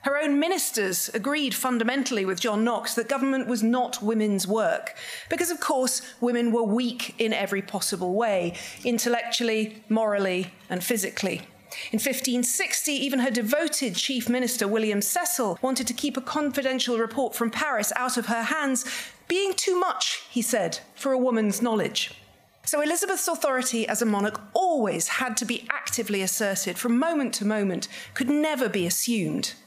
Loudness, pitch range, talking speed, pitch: -25 LUFS, 220-275 Hz, 160 wpm, 240 Hz